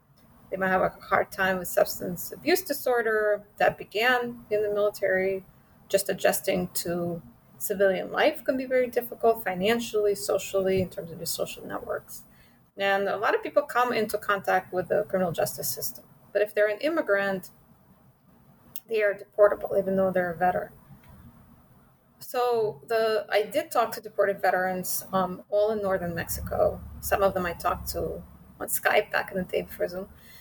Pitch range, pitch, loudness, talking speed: 185-220 Hz, 200 Hz, -27 LUFS, 170 wpm